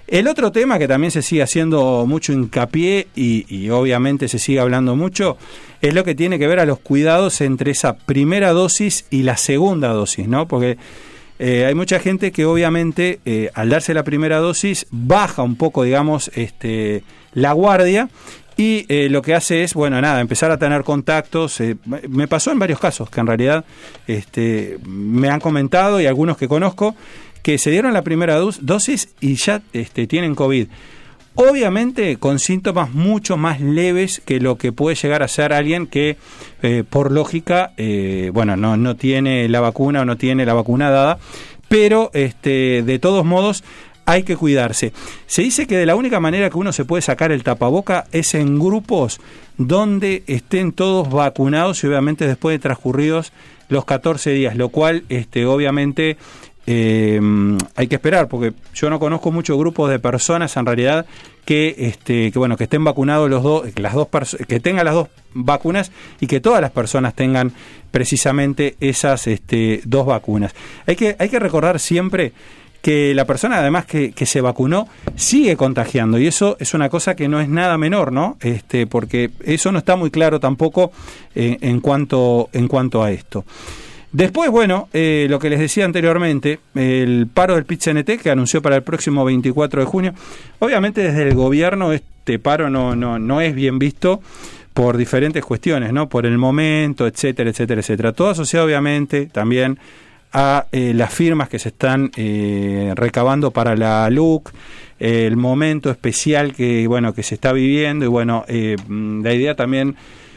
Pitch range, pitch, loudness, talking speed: 125-165 Hz, 145 Hz, -16 LUFS, 175 wpm